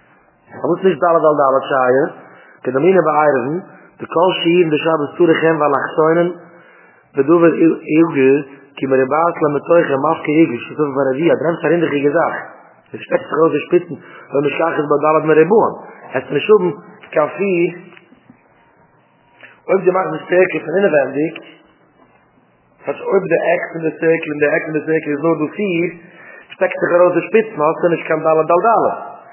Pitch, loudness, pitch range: 160 Hz, -15 LUFS, 150-175 Hz